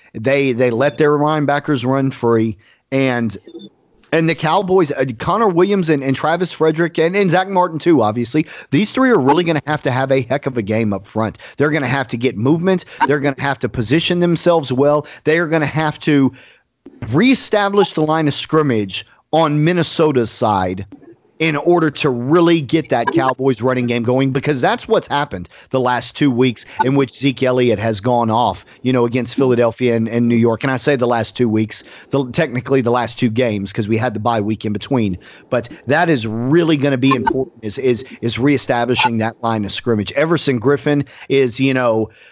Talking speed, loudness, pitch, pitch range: 205 wpm, -16 LUFS, 135 Hz, 120-155 Hz